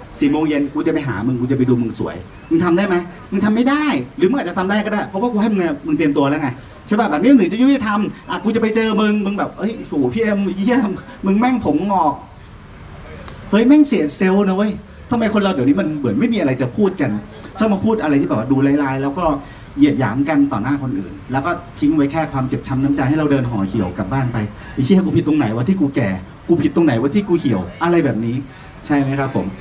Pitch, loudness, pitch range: 155 Hz, -17 LUFS, 135-210 Hz